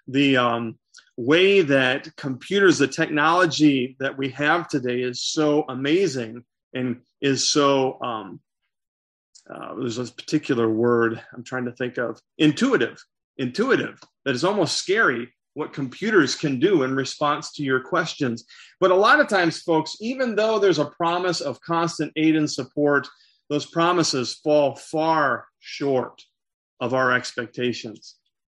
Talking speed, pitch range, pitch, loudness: 140 wpm, 125-160 Hz, 140 Hz, -22 LUFS